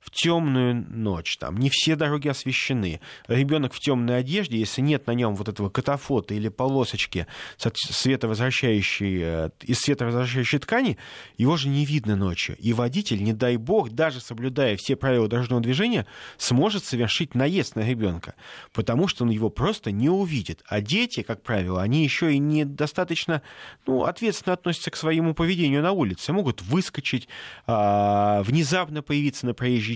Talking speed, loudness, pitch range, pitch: 150 wpm, -24 LUFS, 110-150 Hz, 130 Hz